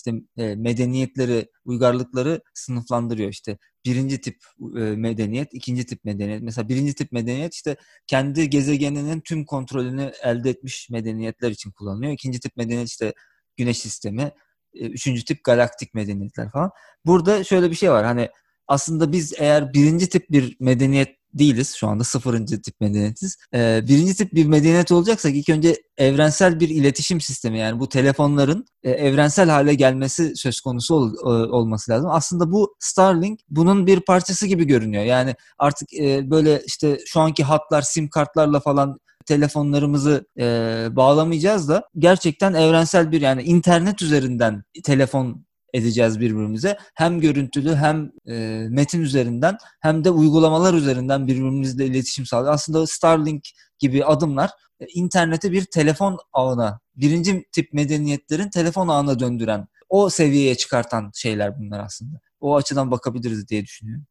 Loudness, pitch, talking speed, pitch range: -20 LUFS, 140 Hz, 135 wpm, 120-160 Hz